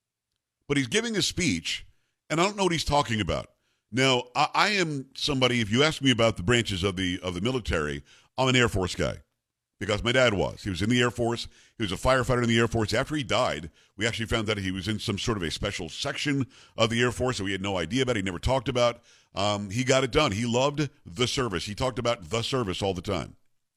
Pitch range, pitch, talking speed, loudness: 105-130 Hz, 120 Hz, 255 wpm, -26 LUFS